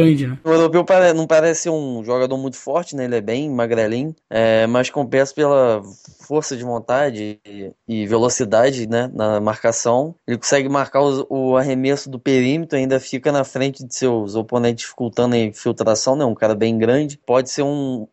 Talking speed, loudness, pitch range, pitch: 165 wpm, -18 LUFS, 115-140 Hz, 130 Hz